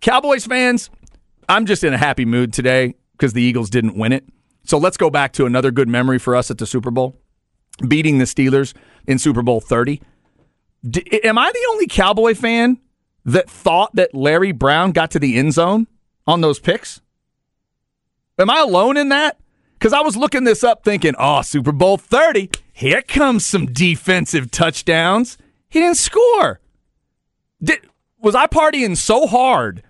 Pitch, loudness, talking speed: 170 Hz, -15 LUFS, 175 wpm